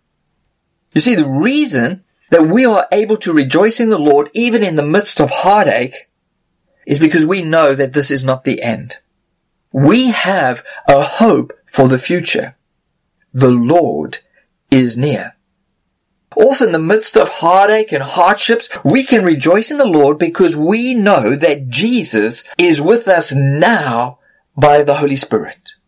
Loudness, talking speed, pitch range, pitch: -12 LUFS, 155 wpm, 140-215 Hz, 160 Hz